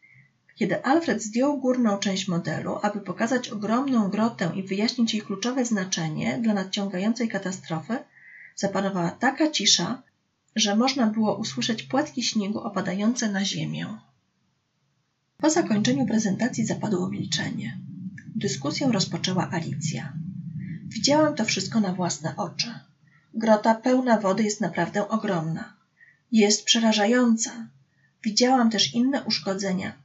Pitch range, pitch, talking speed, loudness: 185-230 Hz, 210 Hz, 110 wpm, -24 LUFS